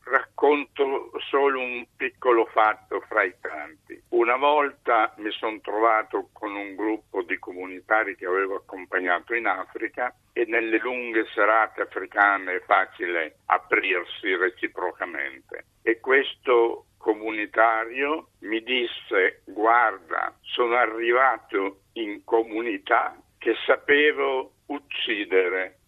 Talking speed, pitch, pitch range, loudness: 105 wpm, 125 Hz, 110-145 Hz, -24 LUFS